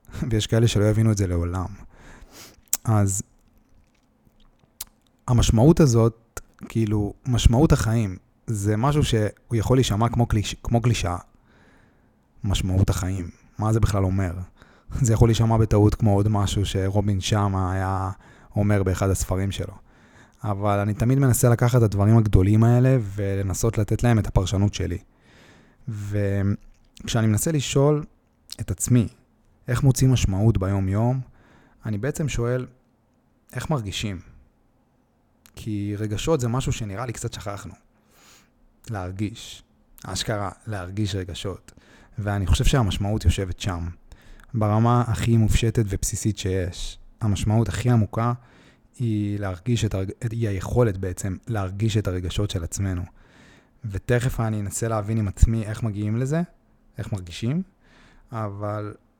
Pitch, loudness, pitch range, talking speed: 110 Hz, -23 LUFS, 100-120 Hz, 120 wpm